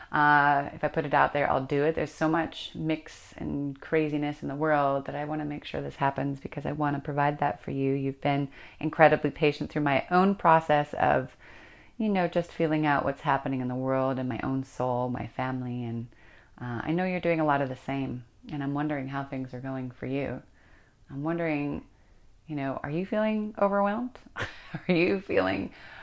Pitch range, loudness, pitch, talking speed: 130-155 Hz, -28 LUFS, 145 Hz, 210 wpm